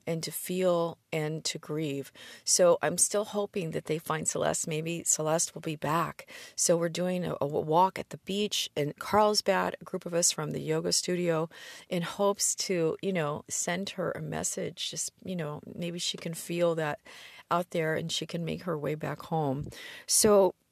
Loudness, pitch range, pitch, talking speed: -29 LUFS, 160-195 Hz, 170 Hz, 190 wpm